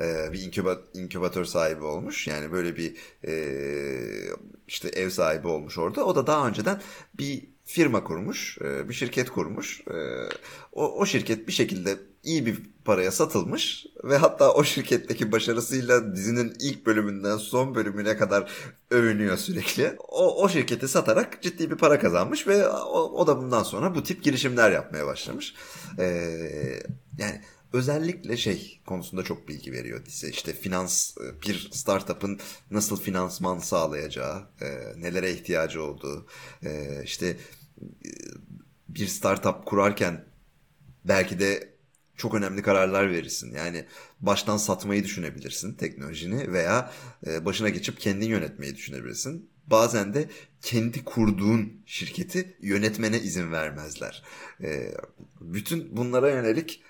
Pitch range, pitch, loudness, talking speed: 90-140 Hz, 105 Hz, -27 LUFS, 125 wpm